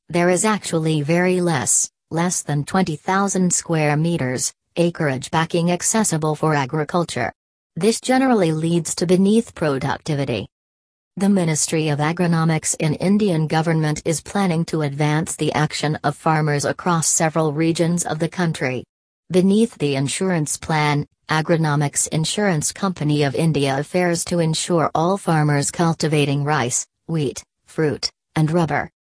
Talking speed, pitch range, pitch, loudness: 130 wpm, 150-175 Hz, 160 Hz, -19 LUFS